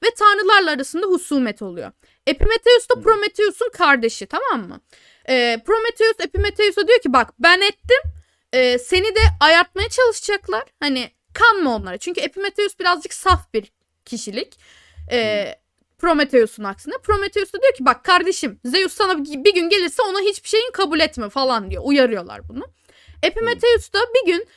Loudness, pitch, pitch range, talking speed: -17 LUFS, 380 Hz, 280-430 Hz, 145 wpm